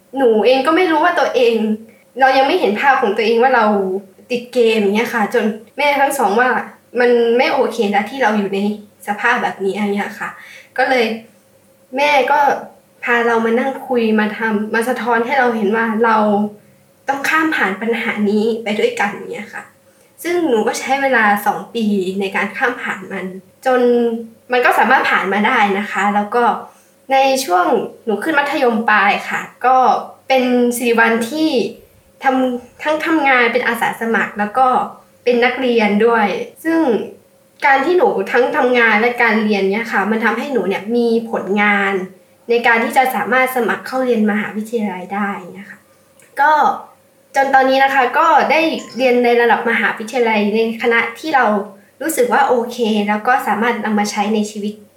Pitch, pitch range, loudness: 235 Hz, 210-260 Hz, -15 LUFS